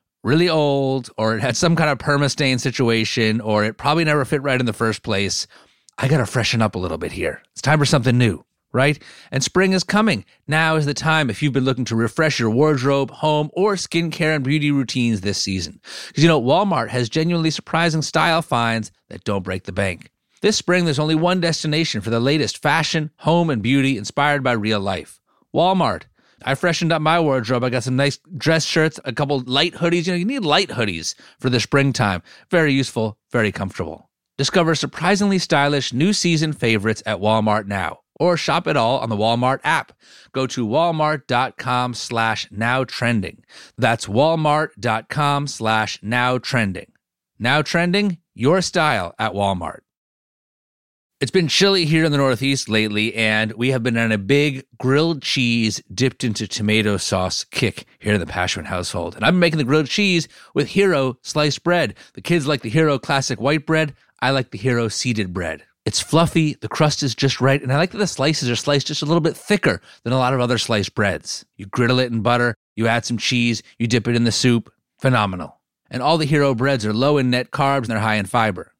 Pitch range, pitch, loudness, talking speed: 115-155 Hz, 135 Hz, -19 LUFS, 200 wpm